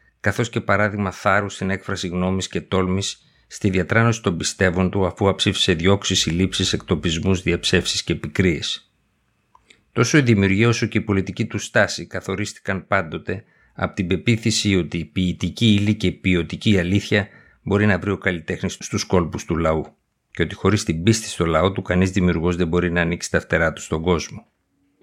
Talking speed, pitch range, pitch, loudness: 175 wpm, 90-105 Hz, 95 Hz, -20 LUFS